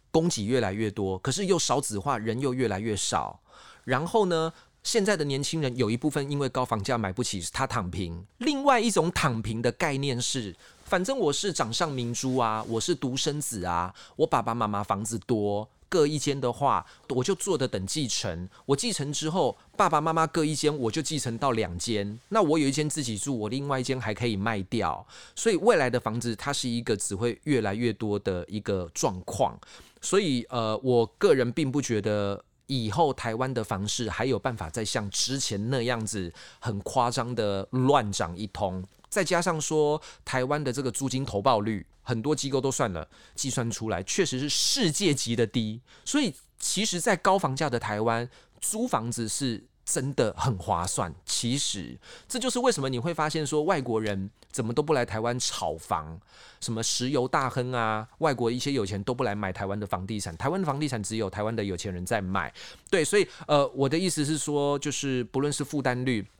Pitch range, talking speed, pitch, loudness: 110-145 Hz, 285 characters per minute, 125 Hz, -28 LUFS